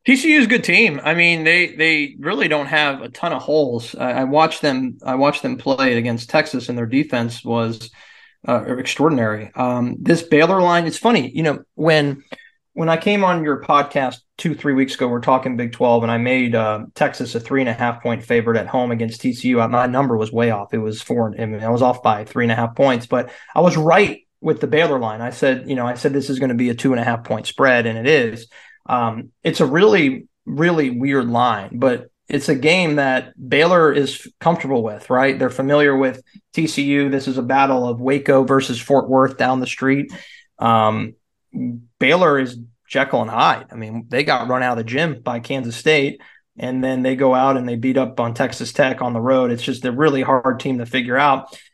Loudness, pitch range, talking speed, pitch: -18 LUFS, 120-145 Hz, 225 wpm, 130 Hz